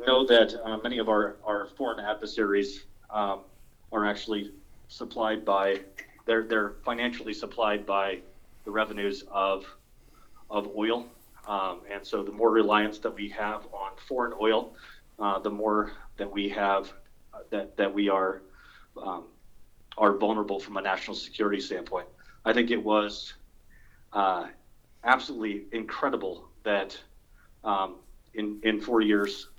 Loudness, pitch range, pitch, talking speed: -29 LUFS, 100-110 Hz, 105 Hz, 140 wpm